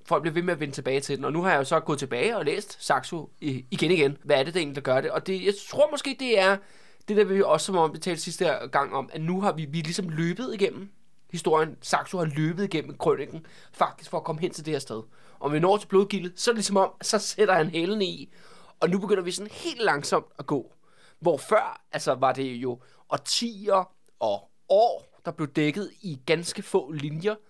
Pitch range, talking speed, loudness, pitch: 155-195 Hz, 245 wpm, -26 LUFS, 175 Hz